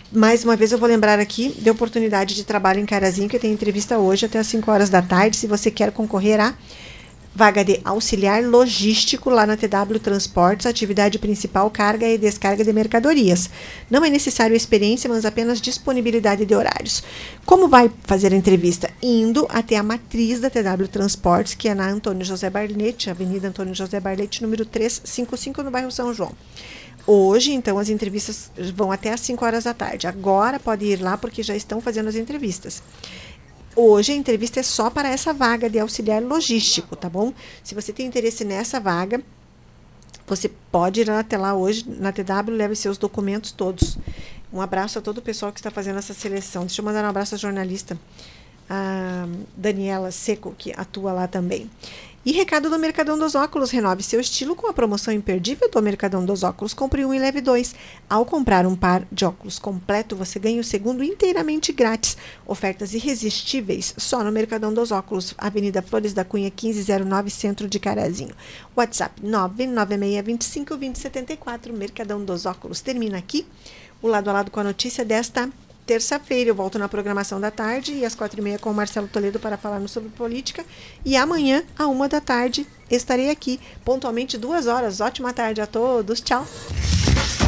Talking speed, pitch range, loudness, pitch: 180 wpm, 200-240 Hz, -21 LUFS, 215 Hz